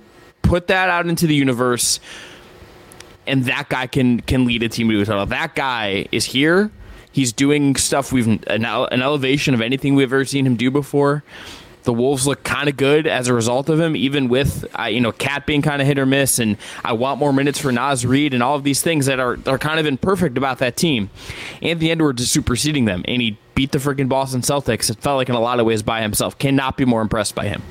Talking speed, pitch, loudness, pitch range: 235 wpm, 135 Hz, -18 LUFS, 120-145 Hz